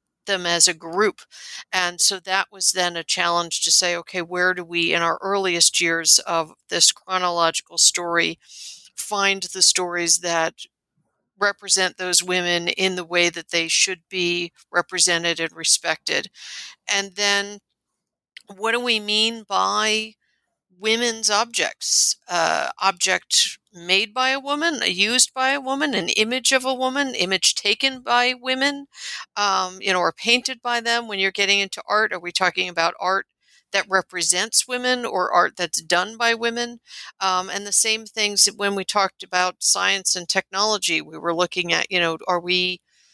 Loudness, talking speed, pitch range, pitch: -20 LUFS, 160 wpm, 175-220 Hz, 190 Hz